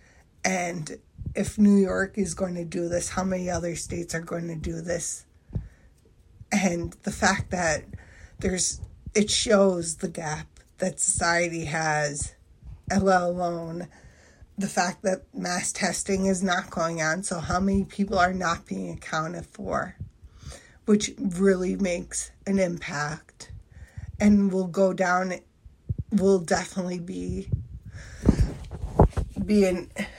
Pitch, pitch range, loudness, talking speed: 175 Hz, 155-190 Hz, -26 LUFS, 125 wpm